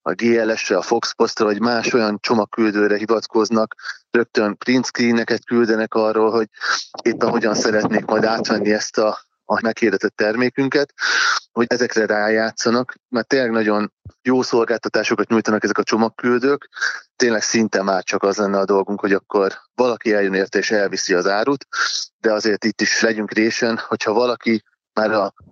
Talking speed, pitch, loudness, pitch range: 155 wpm, 110 Hz, -19 LUFS, 105-120 Hz